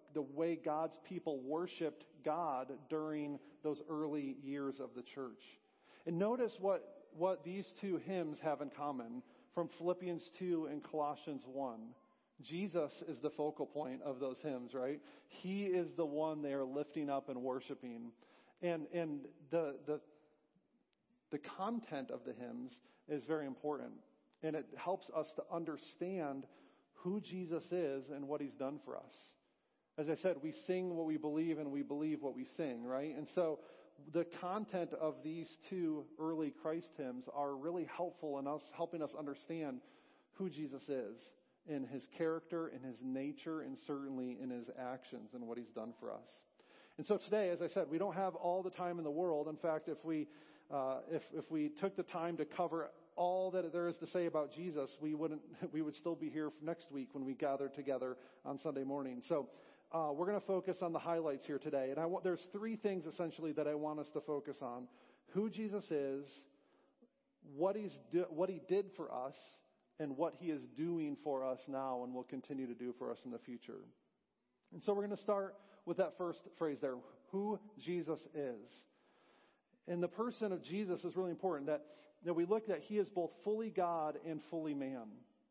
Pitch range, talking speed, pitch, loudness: 145-175 Hz, 190 wpm, 155 Hz, -42 LUFS